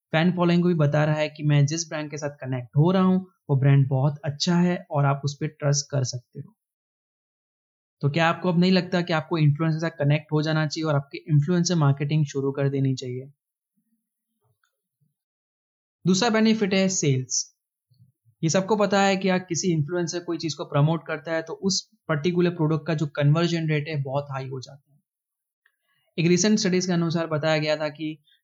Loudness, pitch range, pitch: -23 LUFS, 145-175 Hz, 160 Hz